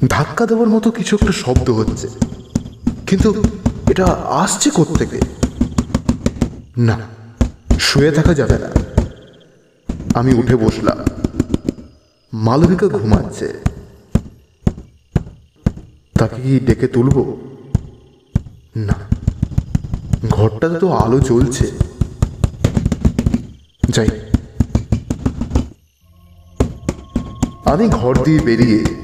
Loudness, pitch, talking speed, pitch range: -17 LUFS, 115 Hz, 75 wpm, 110-130 Hz